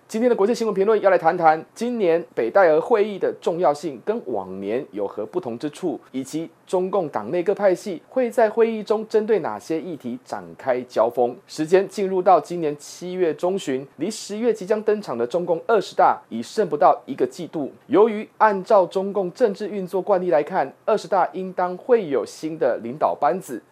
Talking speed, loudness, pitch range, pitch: 295 characters per minute, -22 LUFS, 160-215 Hz, 190 Hz